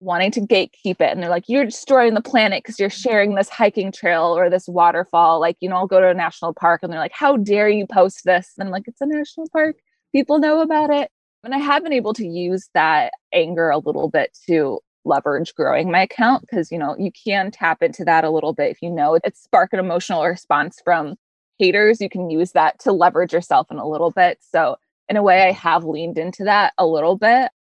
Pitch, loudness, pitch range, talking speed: 190 Hz, -18 LUFS, 170-230 Hz, 235 wpm